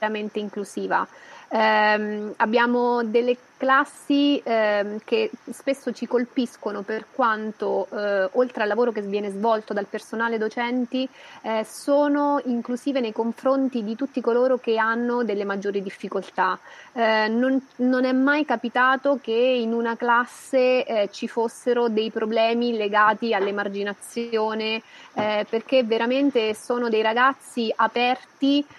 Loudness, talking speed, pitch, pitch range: -23 LUFS, 125 wpm, 230 Hz, 215-255 Hz